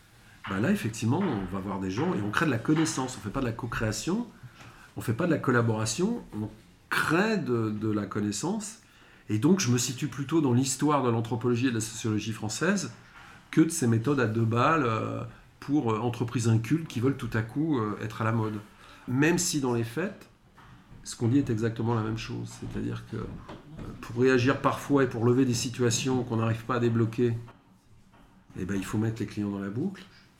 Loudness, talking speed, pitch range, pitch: -28 LUFS, 210 wpm, 110-135 Hz, 120 Hz